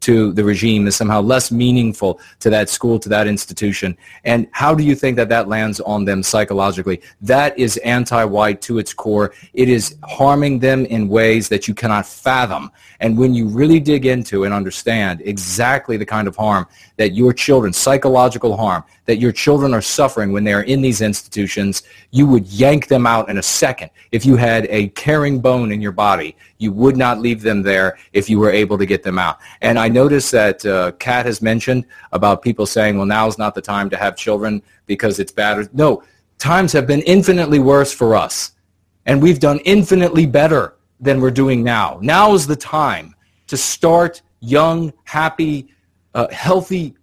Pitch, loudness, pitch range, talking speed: 115 Hz, -15 LUFS, 105-135 Hz, 190 wpm